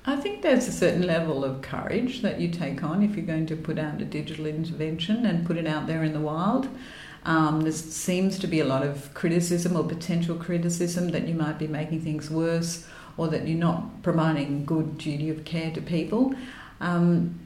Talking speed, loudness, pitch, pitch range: 205 wpm, -27 LUFS, 165 Hz, 155-175 Hz